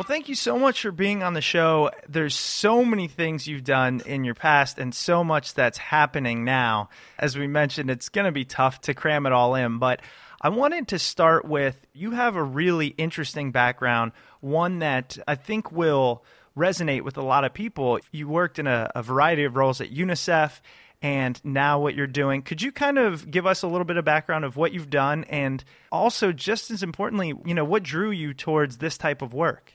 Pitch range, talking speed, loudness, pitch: 135-175 Hz, 215 wpm, -24 LUFS, 150 Hz